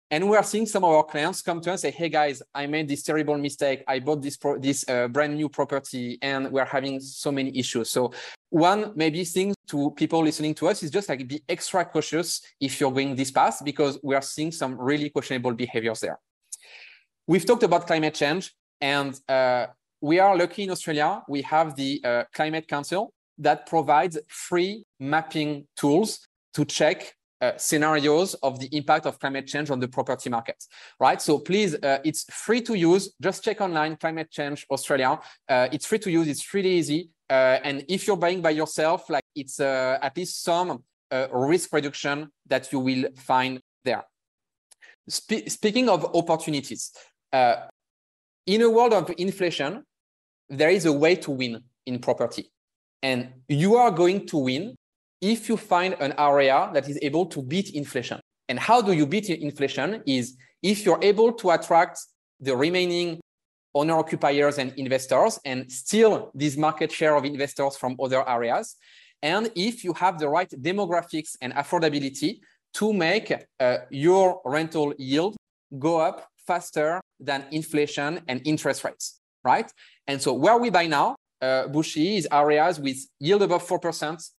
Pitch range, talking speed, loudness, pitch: 135-175 Hz, 175 wpm, -24 LUFS, 150 Hz